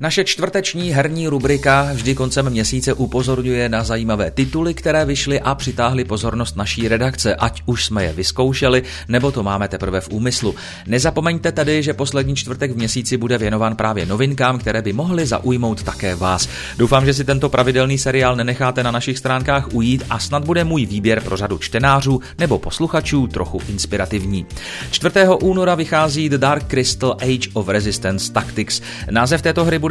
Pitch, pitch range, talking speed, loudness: 125 Hz, 110-140 Hz, 165 wpm, -17 LUFS